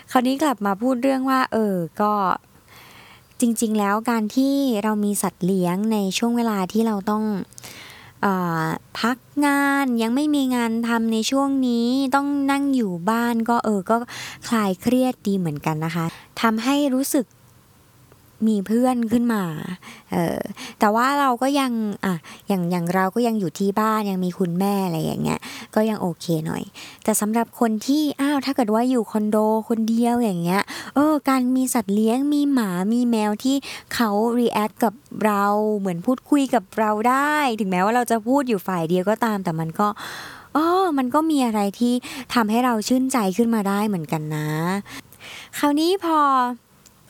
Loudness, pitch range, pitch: -21 LUFS, 200-255 Hz, 225 Hz